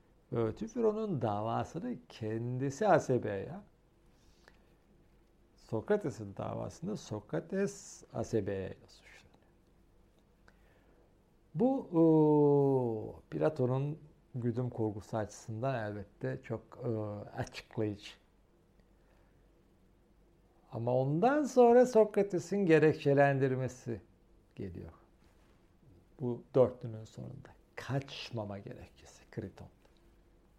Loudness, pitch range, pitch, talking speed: -33 LUFS, 110-150 Hz, 125 Hz, 60 wpm